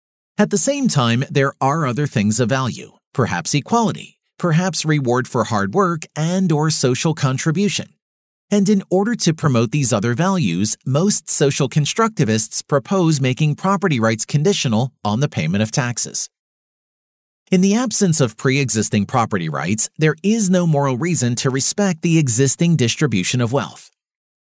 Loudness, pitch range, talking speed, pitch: -18 LUFS, 125-180 Hz, 150 wpm, 150 Hz